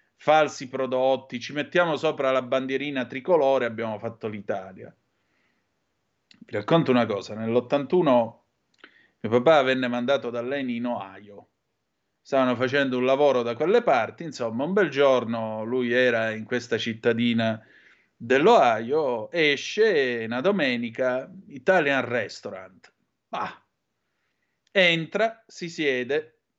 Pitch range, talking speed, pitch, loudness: 120-160 Hz, 115 wpm, 130 Hz, -24 LUFS